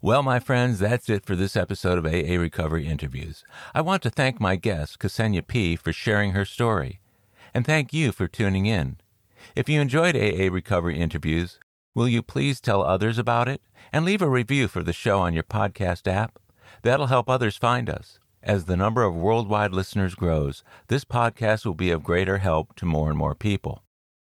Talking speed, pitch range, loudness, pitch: 195 wpm, 90-120 Hz, -24 LUFS, 105 Hz